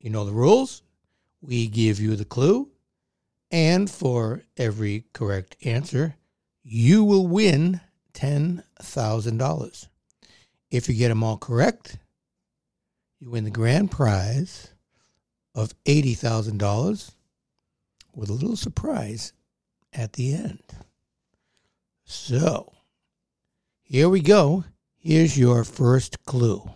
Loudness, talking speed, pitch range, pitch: -23 LUFS, 105 wpm, 110-160 Hz, 125 Hz